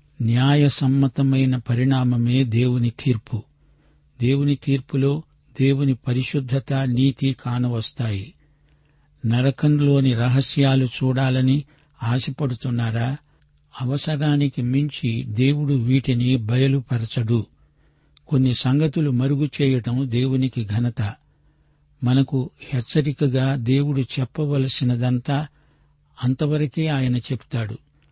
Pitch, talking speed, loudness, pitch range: 135 Hz, 70 wpm, -21 LUFS, 125-145 Hz